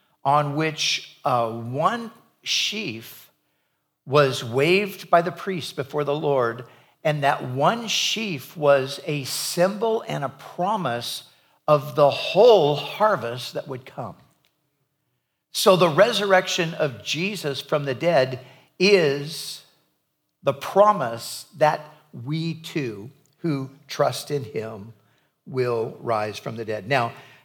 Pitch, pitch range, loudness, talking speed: 145 Hz, 130-175 Hz, -22 LUFS, 120 wpm